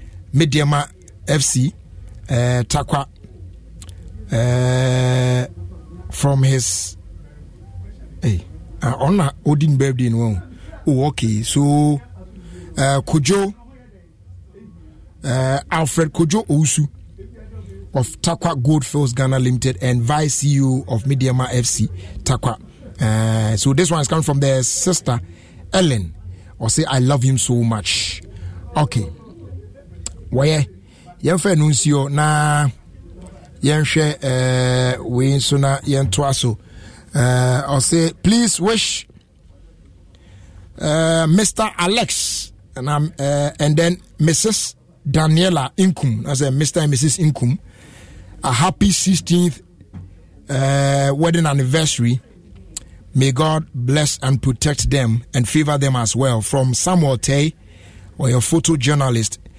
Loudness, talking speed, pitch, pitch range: -17 LUFS, 100 wpm, 130 Hz, 95-150 Hz